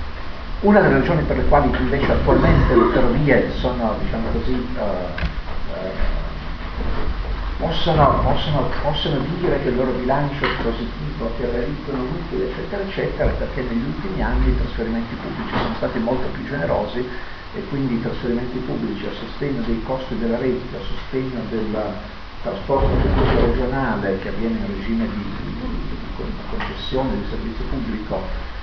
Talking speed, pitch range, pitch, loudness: 140 wpm, 90-125 Hz, 115 Hz, -22 LUFS